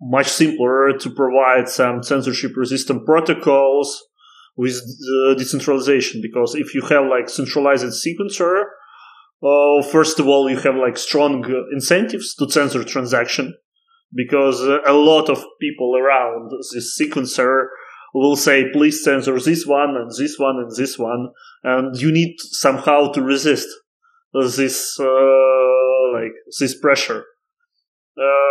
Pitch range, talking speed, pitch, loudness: 130-150 Hz, 135 wpm, 140 Hz, -17 LUFS